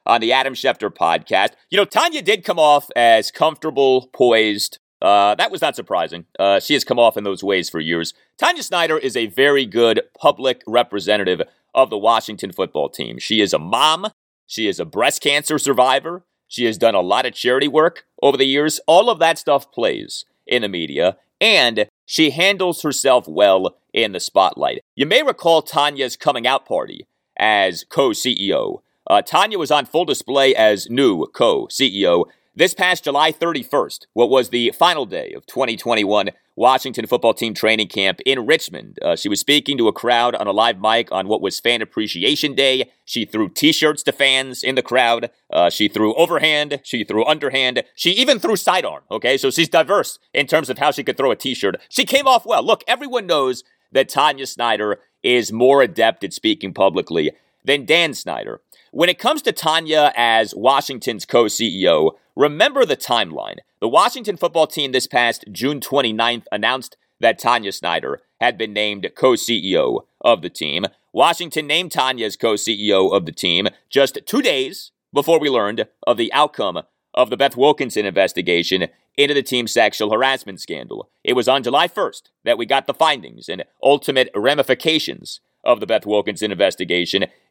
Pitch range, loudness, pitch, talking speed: 115-165 Hz, -17 LUFS, 140 Hz, 180 wpm